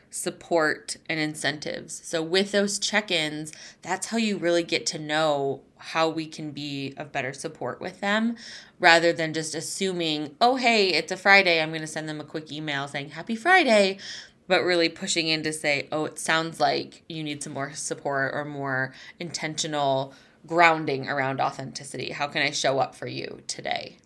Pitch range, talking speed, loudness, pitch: 145-180 Hz, 180 wpm, -25 LUFS, 160 Hz